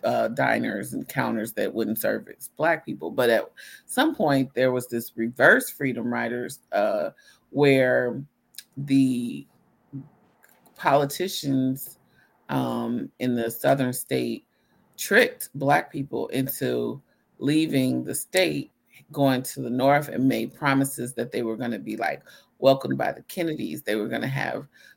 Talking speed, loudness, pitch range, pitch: 140 wpm, -25 LUFS, 120-140 Hz, 130 Hz